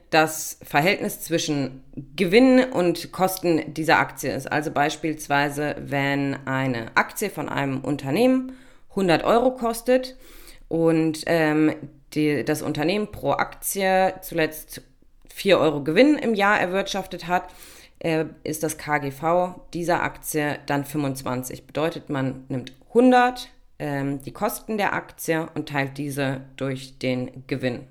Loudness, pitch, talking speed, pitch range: -23 LUFS, 155 Hz, 125 wpm, 140-185 Hz